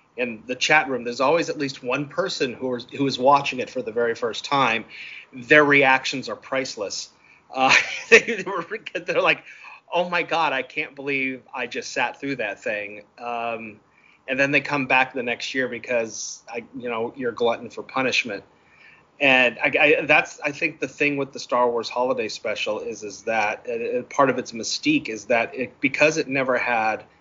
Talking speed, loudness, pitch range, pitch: 195 wpm, -22 LUFS, 125-175 Hz, 140 Hz